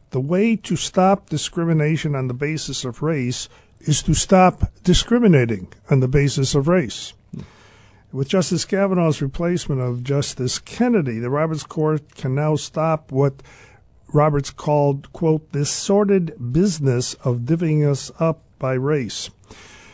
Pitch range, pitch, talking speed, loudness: 125-165 Hz, 145 Hz, 135 wpm, -20 LUFS